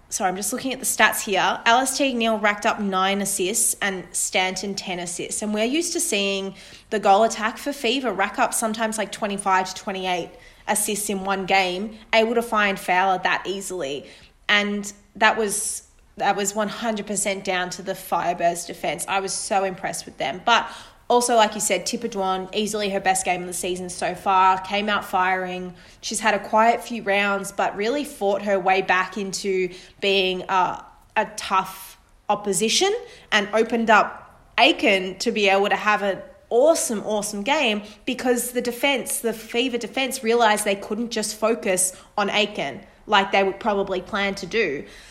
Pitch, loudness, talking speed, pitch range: 205 Hz, -22 LUFS, 180 wpm, 190-225 Hz